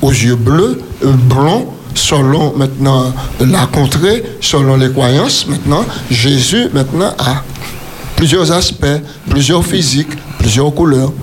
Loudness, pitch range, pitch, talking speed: -11 LUFS, 130-150 Hz, 140 Hz, 110 wpm